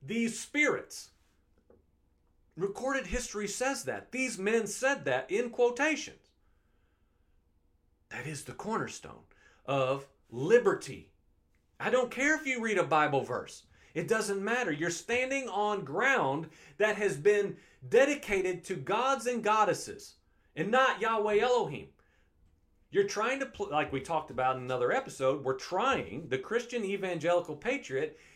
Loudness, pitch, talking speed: -31 LUFS, 190 Hz, 135 wpm